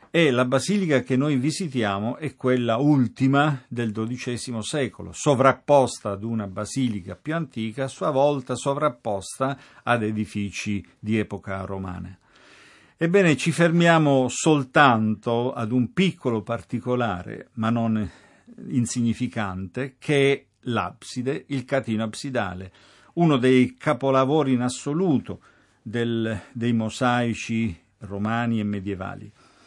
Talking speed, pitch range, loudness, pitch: 110 wpm, 110-140 Hz, -23 LUFS, 125 Hz